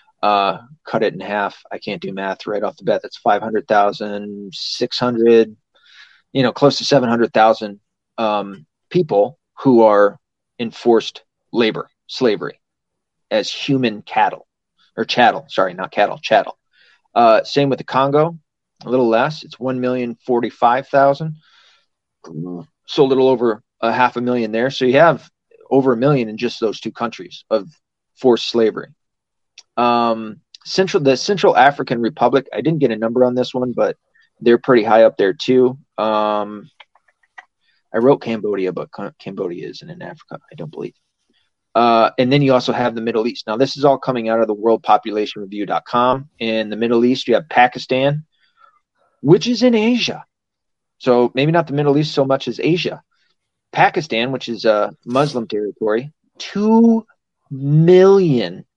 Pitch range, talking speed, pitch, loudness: 110-140 Hz, 155 wpm, 125 Hz, -17 LUFS